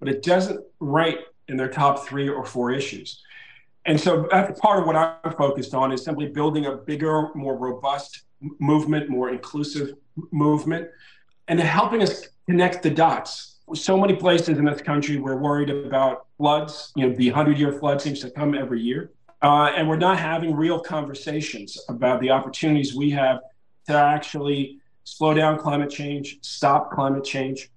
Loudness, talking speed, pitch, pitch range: -22 LUFS, 170 wpm, 145 Hz, 135-155 Hz